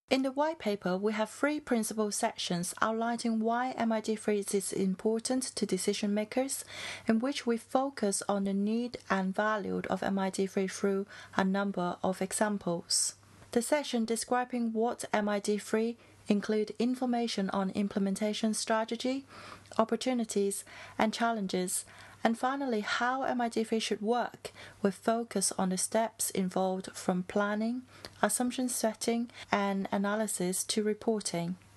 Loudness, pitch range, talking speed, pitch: -32 LUFS, 200-235 Hz, 125 wpm, 215 Hz